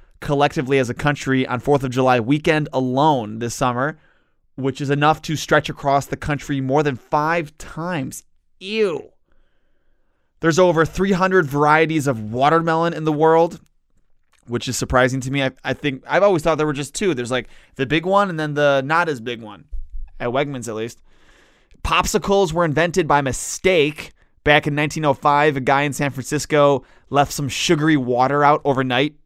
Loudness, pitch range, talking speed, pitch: -19 LUFS, 130-160 Hz, 170 wpm, 145 Hz